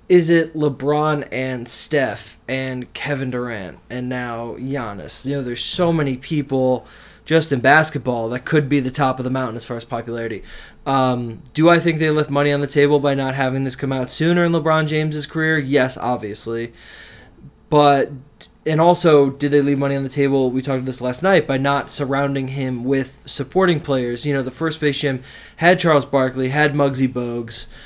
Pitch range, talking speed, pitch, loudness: 125-150 Hz, 195 wpm, 135 Hz, -19 LUFS